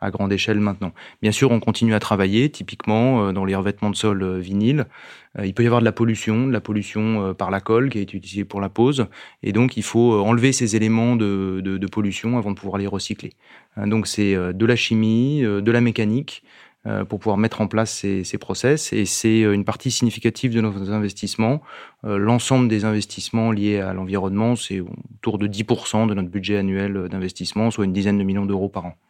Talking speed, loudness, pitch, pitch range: 205 wpm, -21 LUFS, 105 Hz, 100-115 Hz